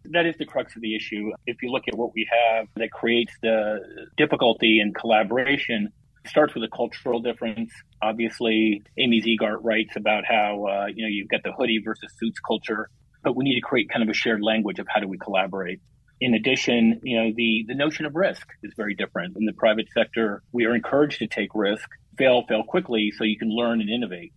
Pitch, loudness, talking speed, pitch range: 115 Hz, -23 LUFS, 215 wpm, 110-120 Hz